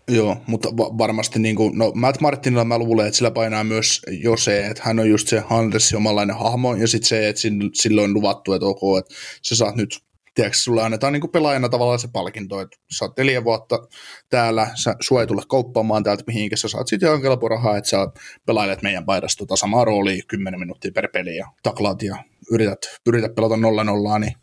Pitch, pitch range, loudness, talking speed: 110 Hz, 105-115 Hz, -19 LUFS, 215 wpm